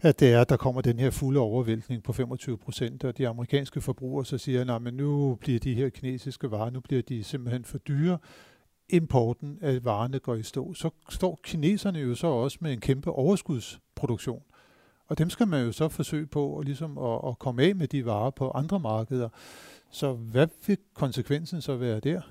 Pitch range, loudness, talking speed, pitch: 125-150 Hz, -29 LUFS, 200 wpm, 135 Hz